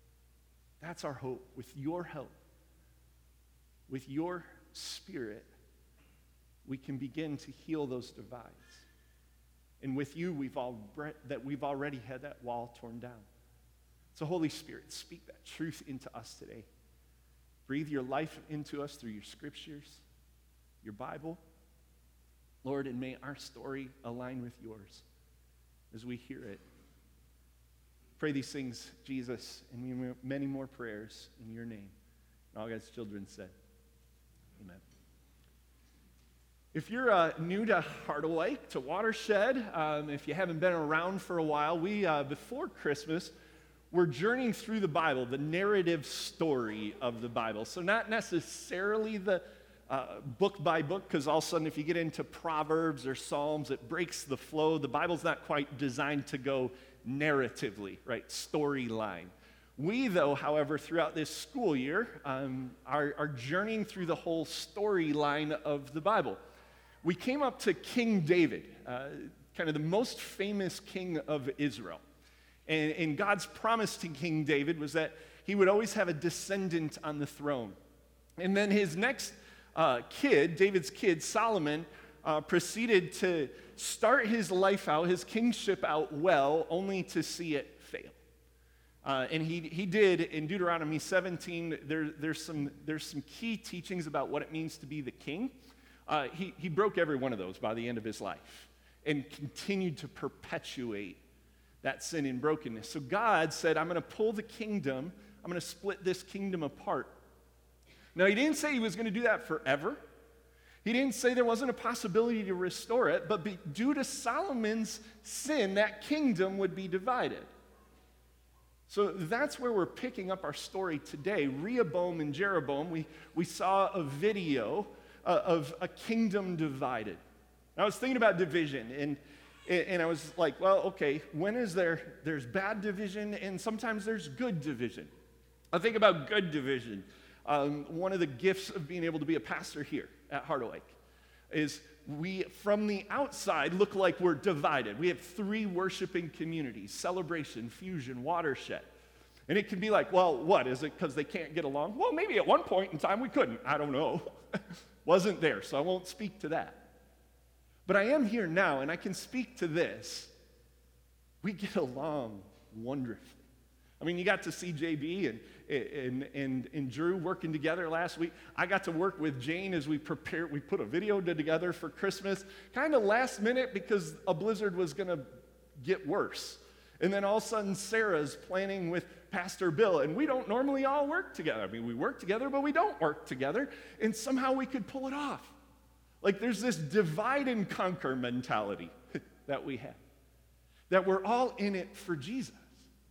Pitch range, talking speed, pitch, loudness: 130-195 Hz, 170 wpm, 160 Hz, -34 LUFS